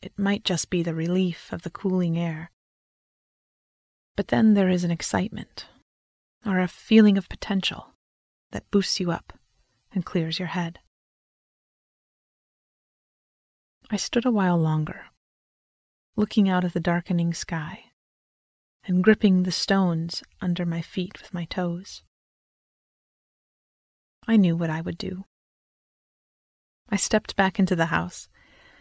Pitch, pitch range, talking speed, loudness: 180 Hz, 165-195 Hz, 130 wpm, -24 LUFS